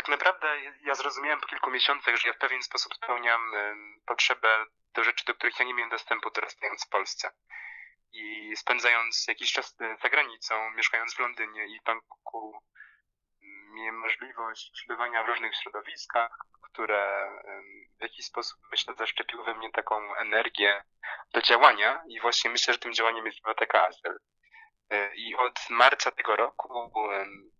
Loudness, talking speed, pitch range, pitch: -27 LUFS, 150 wpm, 110-125 Hz, 115 Hz